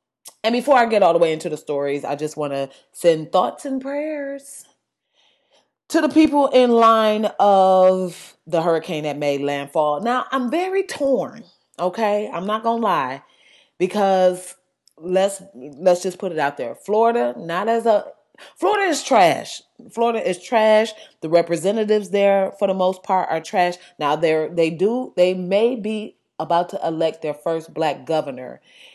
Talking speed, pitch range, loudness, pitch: 165 wpm, 165-230 Hz, -19 LUFS, 190 Hz